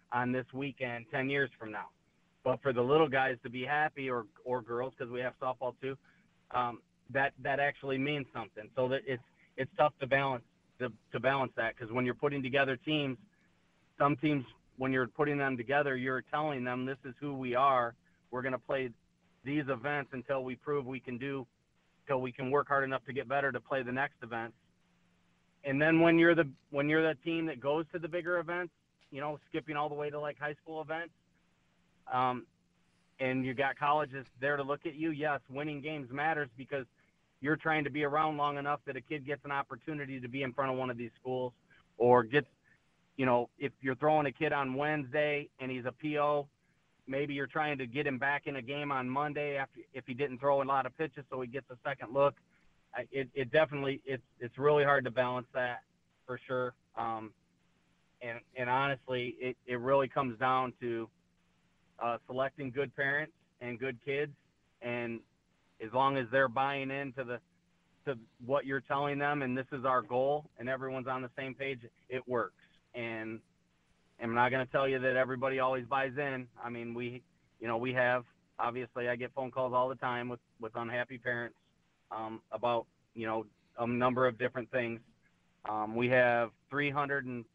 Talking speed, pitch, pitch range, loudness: 200 wpm, 135 Hz, 125-145 Hz, -34 LUFS